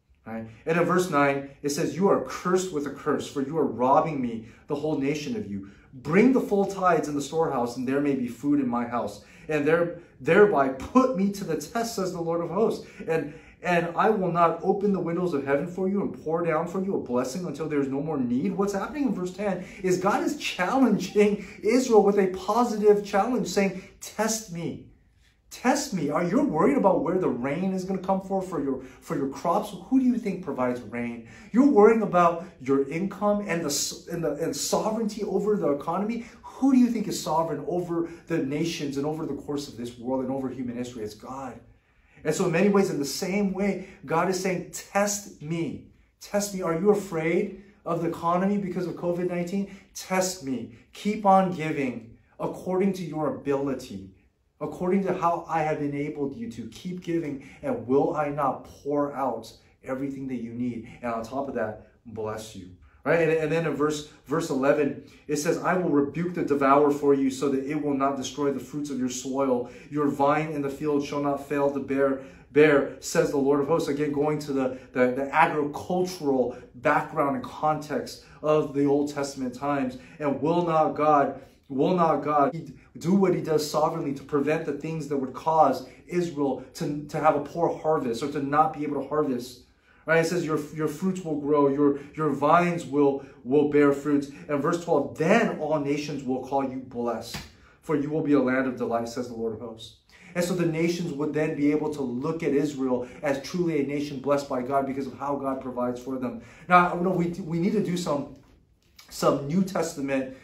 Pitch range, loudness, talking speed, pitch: 140-180 Hz, -26 LUFS, 210 wpm, 150 Hz